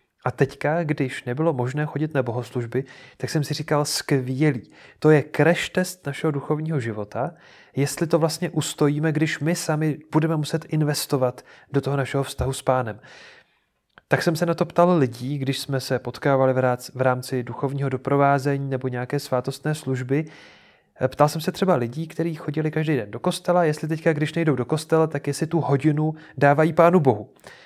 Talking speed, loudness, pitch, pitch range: 170 wpm, -23 LUFS, 145 Hz, 130-160 Hz